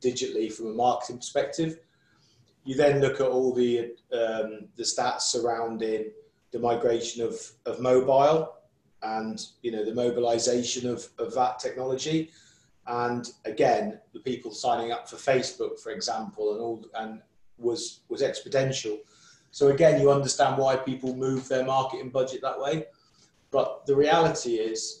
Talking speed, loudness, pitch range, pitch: 145 wpm, -27 LUFS, 115-140 Hz, 125 Hz